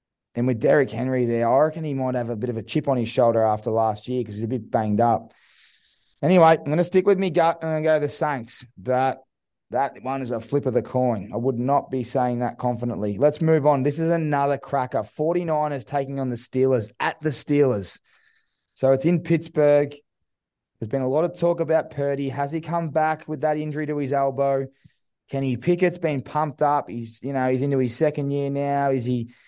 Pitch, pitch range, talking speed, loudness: 140 Hz, 125-155 Hz, 230 wpm, -23 LUFS